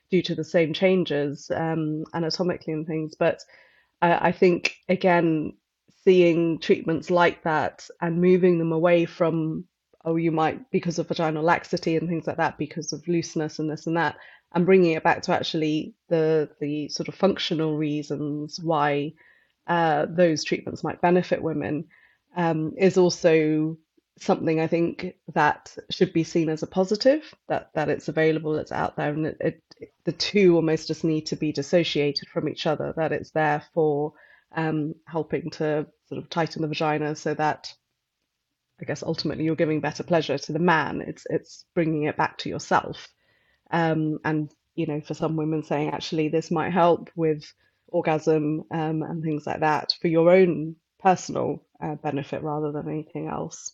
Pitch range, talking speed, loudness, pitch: 155-170 Hz, 170 wpm, -24 LUFS, 160 Hz